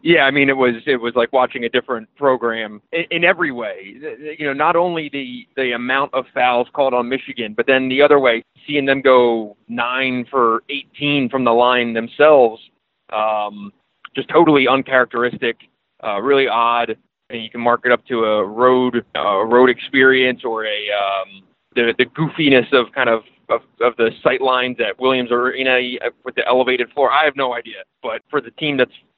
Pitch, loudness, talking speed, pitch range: 125 Hz, -17 LUFS, 190 wpm, 115-135 Hz